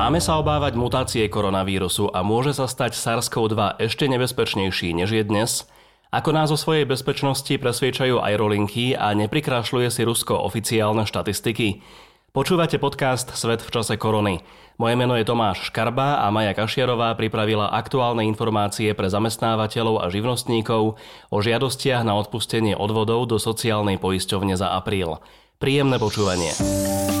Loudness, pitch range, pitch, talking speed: -22 LUFS, 105-125 Hz, 110 Hz, 135 wpm